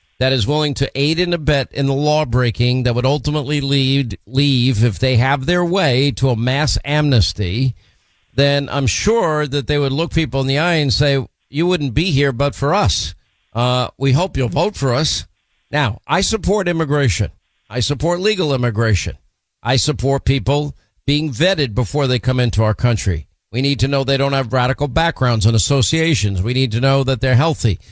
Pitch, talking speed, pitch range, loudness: 135 Hz, 190 wpm, 125-145 Hz, -17 LUFS